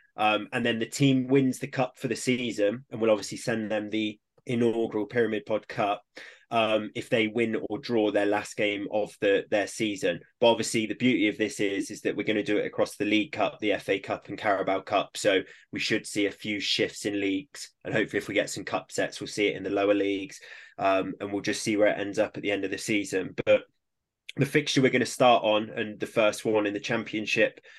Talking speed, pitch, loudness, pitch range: 240 wpm, 110 Hz, -27 LUFS, 105-120 Hz